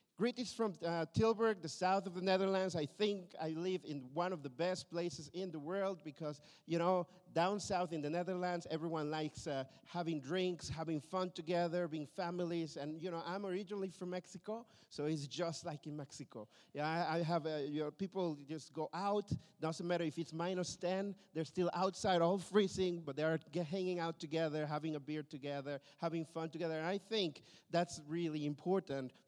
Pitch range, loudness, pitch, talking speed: 155-185 Hz, -40 LUFS, 170 Hz, 195 wpm